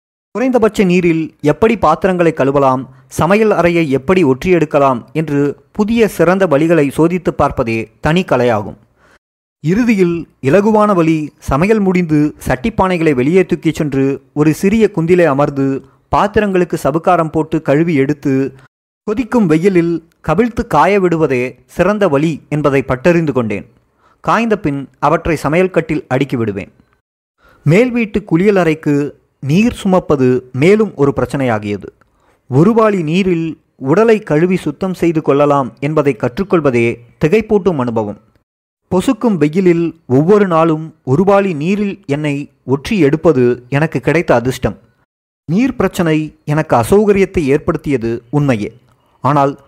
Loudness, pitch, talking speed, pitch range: -13 LUFS, 155 Hz, 105 wpm, 135-185 Hz